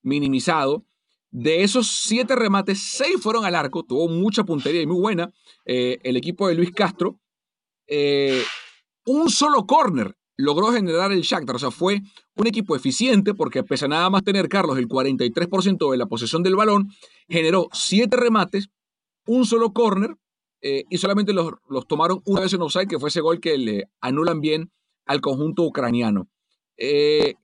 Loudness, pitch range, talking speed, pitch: -21 LUFS, 155-215 Hz, 170 wpm, 185 Hz